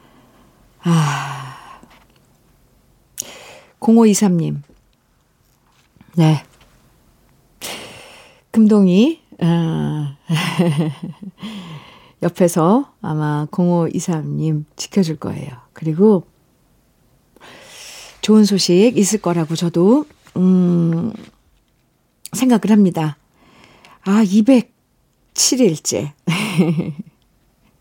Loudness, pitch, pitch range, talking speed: -16 LUFS, 175 Hz, 160-210 Hz, 95 characters per minute